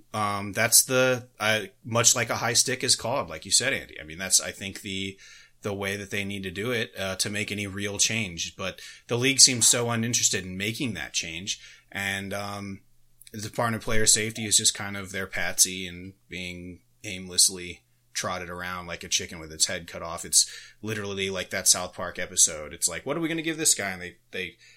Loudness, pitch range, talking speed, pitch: -24 LUFS, 95-115 Hz, 220 wpm, 100 Hz